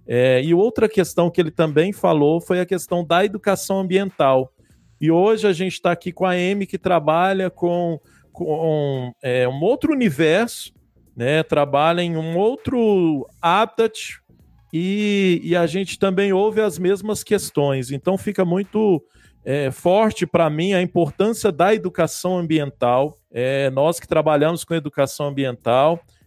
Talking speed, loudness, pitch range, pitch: 150 wpm, -19 LUFS, 150-195 Hz, 175 Hz